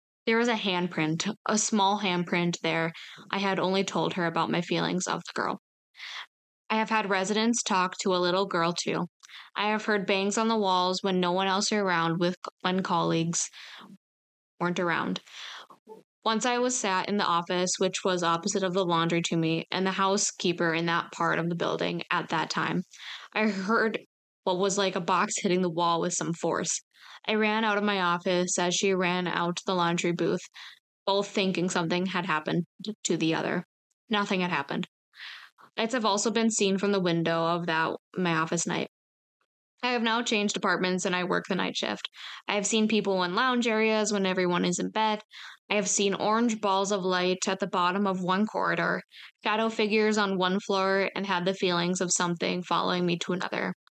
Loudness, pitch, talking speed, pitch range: -27 LUFS, 190 Hz, 195 wpm, 175-210 Hz